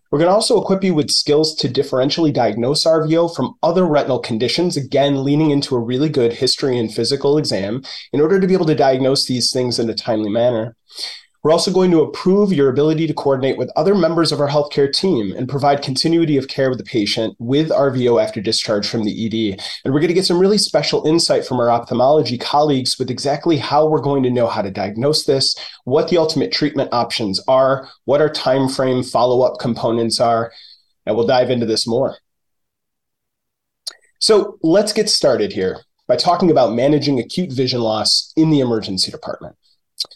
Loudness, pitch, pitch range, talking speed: -16 LUFS, 135 Hz, 120-155 Hz, 195 wpm